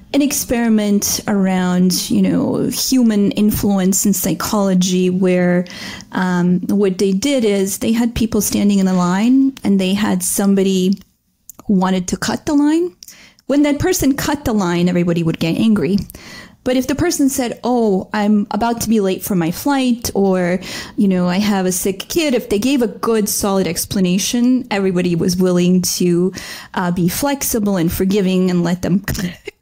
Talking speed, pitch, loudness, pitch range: 170 wpm, 200 Hz, -16 LUFS, 185-235 Hz